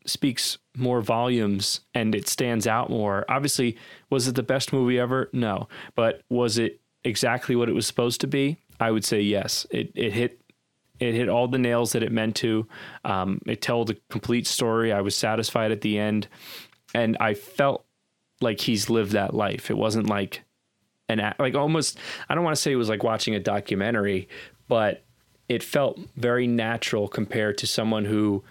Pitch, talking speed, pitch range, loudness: 115 Hz, 185 wpm, 105-125 Hz, -25 LUFS